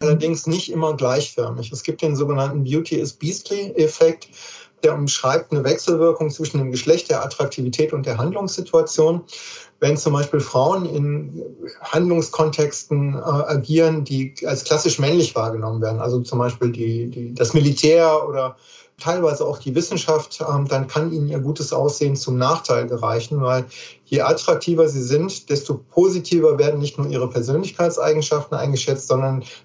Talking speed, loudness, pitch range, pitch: 145 wpm, -20 LUFS, 135-160 Hz, 150 Hz